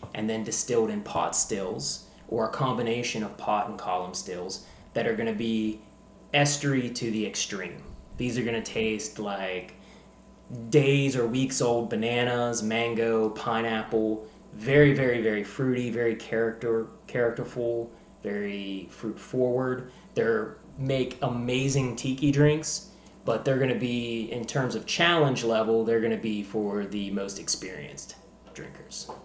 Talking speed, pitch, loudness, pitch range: 145 wpm, 115 Hz, -27 LUFS, 110-130 Hz